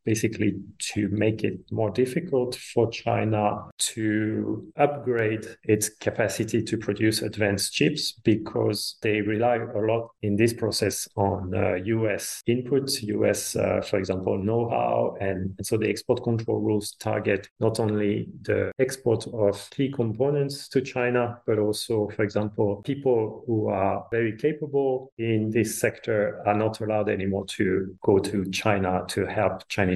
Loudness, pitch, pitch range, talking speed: -26 LUFS, 110 Hz, 105-115 Hz, 145 wpm